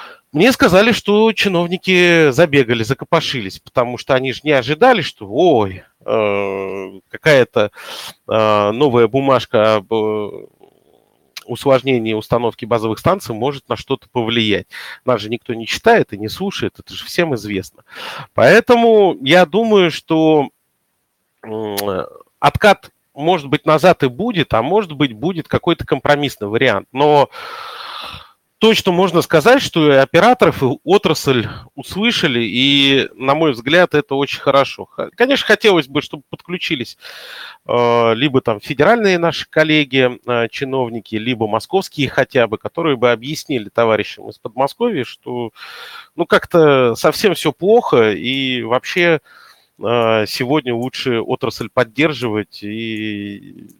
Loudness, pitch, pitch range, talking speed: -15 LUFS, 135 Hz, 115-170 Hz, 120 wpm